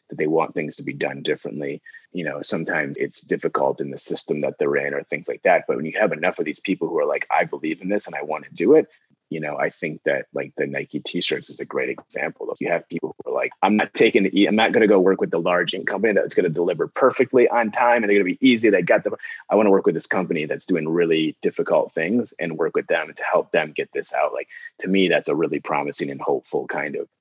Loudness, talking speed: -21 LUFS, 280 wpm